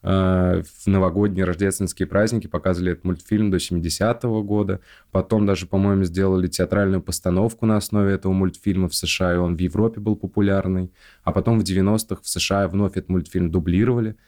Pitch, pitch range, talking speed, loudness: 95 Hz, 90-105 Hz, 160 wpm, -21 LUFS